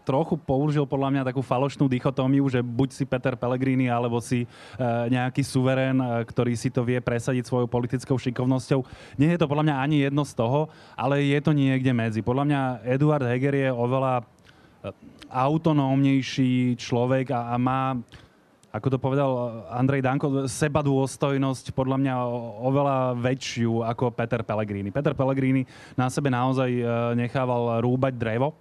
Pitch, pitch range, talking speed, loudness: 130 Hz, 125-135 Hz, 145 wpm, -25 LUFS